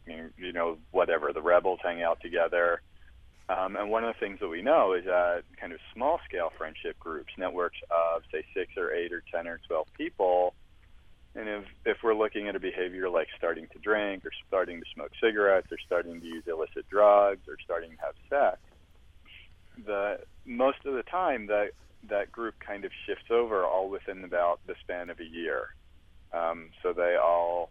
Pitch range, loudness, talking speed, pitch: 85-105 Hz, -30 LUFS, 190 wpm, 90 Hz